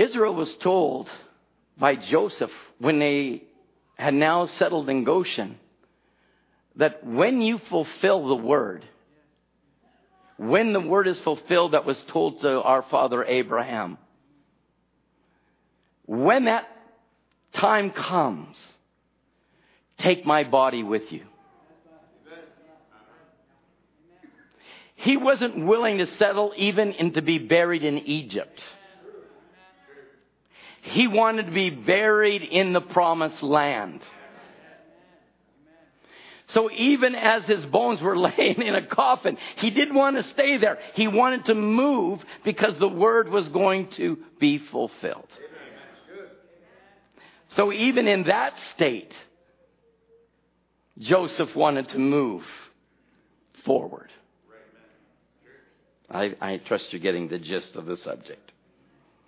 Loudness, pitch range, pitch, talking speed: -23 LUFS, 155-225 Hz, 190 Hz, 110 wpm